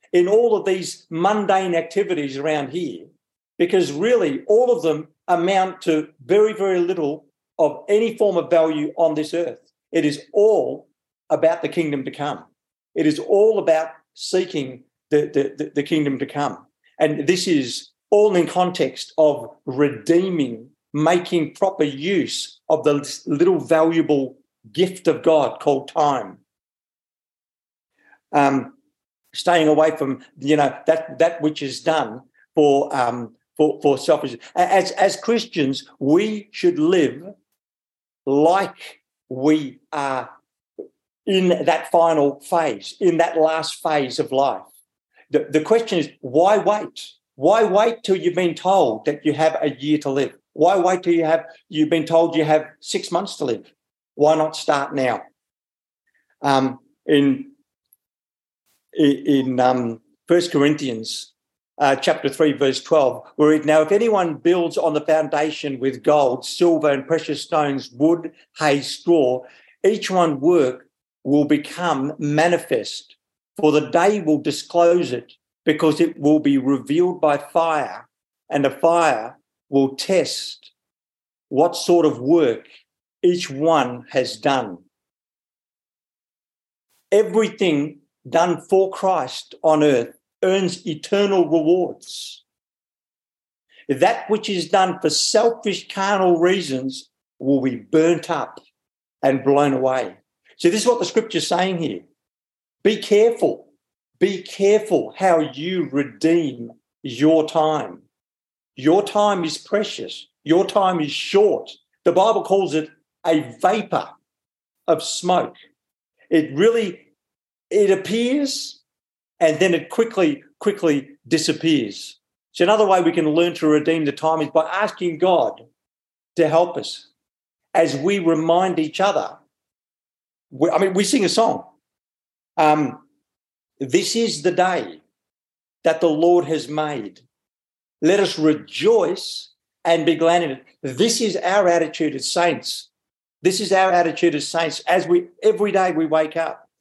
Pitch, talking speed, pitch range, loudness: 165 Hz, 135 wpm, 150-190 Hz, -19 LUFS